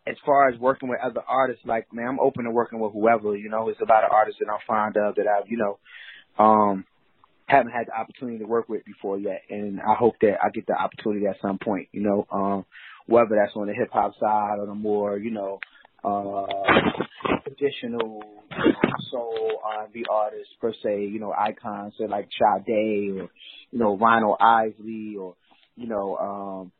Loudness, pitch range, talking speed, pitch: -24 LUFS, 100-115 Hz, 205 wpm, 105 Hz